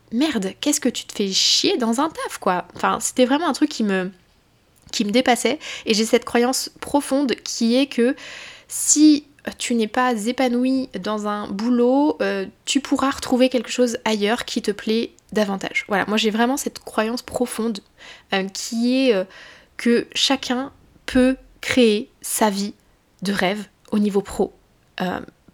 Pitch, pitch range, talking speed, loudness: 240 Hz, 215-265 Hz, 165 wpm, -21 LUFS